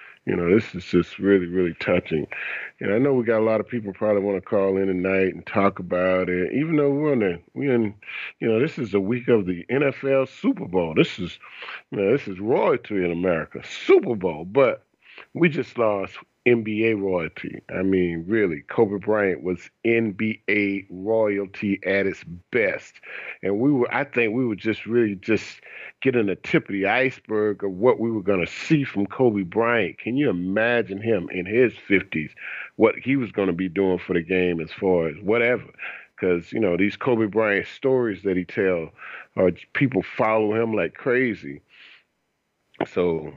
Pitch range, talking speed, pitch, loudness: 95-120 Hz, 190 wpm, 105 Hz, -23 LUFS